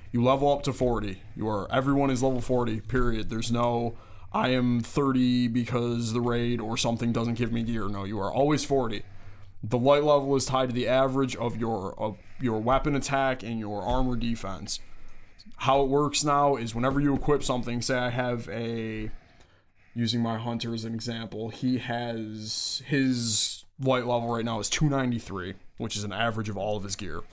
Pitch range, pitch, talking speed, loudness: 110-130 Hz, 120 Hz, 190 wpm, -27 LUFS